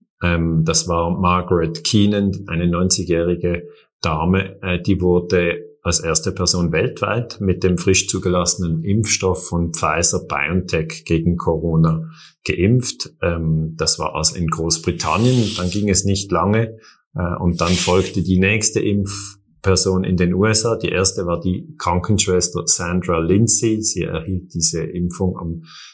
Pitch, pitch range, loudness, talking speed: 90 Hz, 85-95 Hz, -18 LUFS, 125 wpm